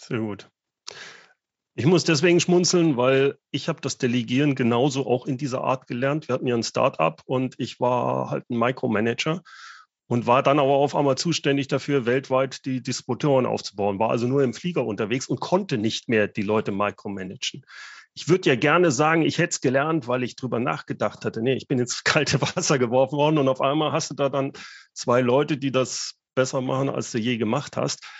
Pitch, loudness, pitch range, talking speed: 130 Hz, -23 LUFS, 125-145 Hz, 200 wpm